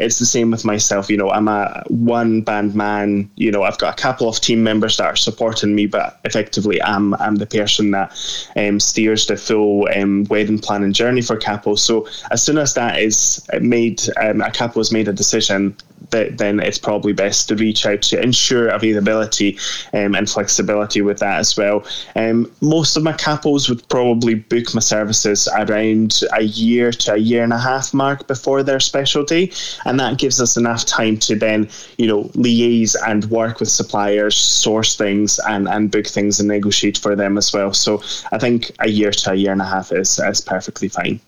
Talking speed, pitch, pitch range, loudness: 205 wpm, 110 Hz, 105-120 Hz, -16 LUFS